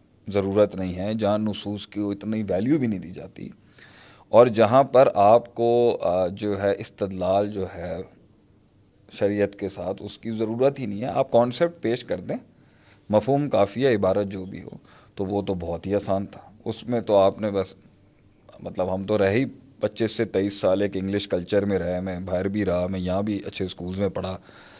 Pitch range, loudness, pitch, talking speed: 95-110 Hz, -24 LUFS, 100 Hz, 195 wpm